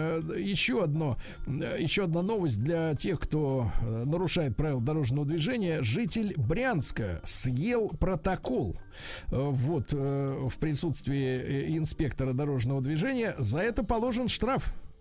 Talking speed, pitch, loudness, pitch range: 105 wpm, 150 Hz, -30 LUFS, 130-175 Hz